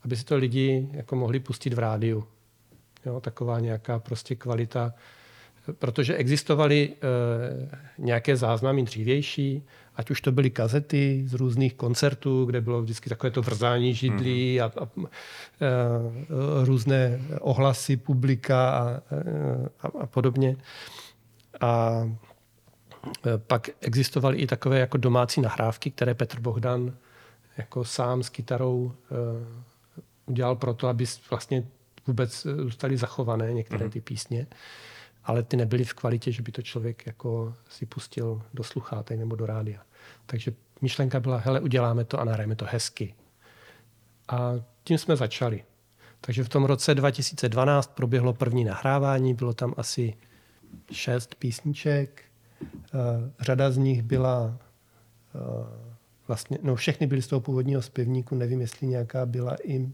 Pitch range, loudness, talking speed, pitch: 115-135 Hz, -27 LUFS, 135 wpm, 125 Hz